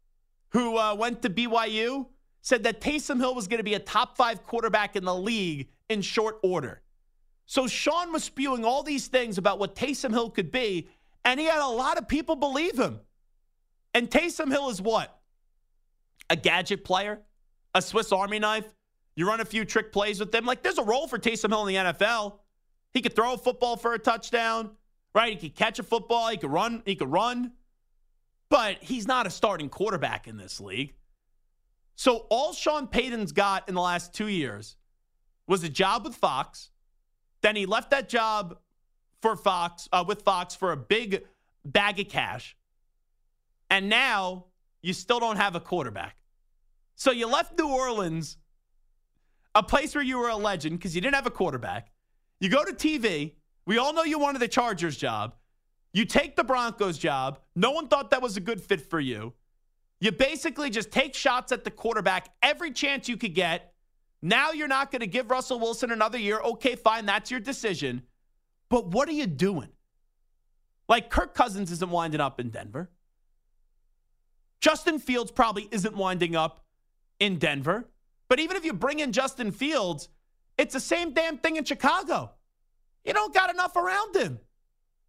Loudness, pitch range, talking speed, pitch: -27 LUFS, 180-255 Hz, 180 wpm, 220 Hz